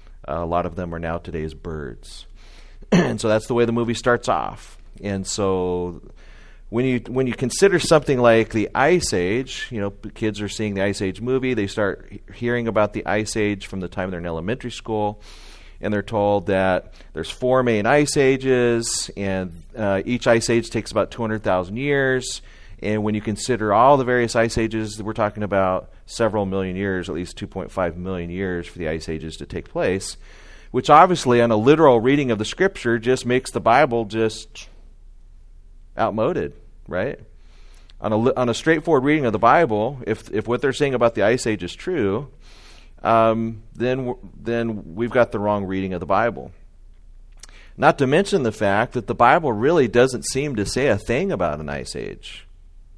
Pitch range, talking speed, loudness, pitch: 95-120 Hz, 195 wpm, -21 LUFS, 110 Hz